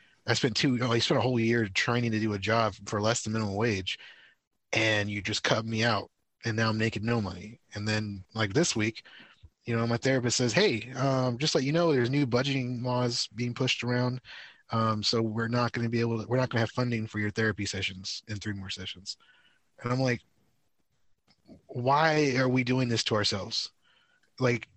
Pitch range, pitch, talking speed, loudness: 110-125 Hz, 115 Hz, 215 wpm, -28 LUFS